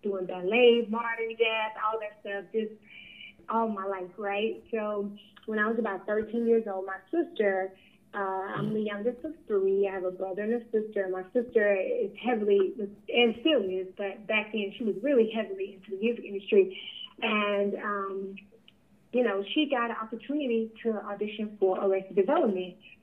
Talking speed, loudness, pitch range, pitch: 170 wpm, -29 LUFS, 195-230 Hz, 210 Hz